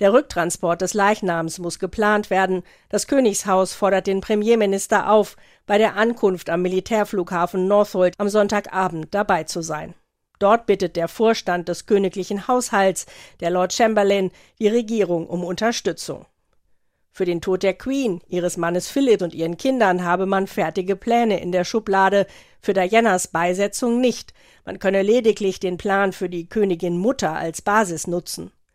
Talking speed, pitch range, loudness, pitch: 150 wpm, 180-210 Hz, -20 LUFS, 195 Hz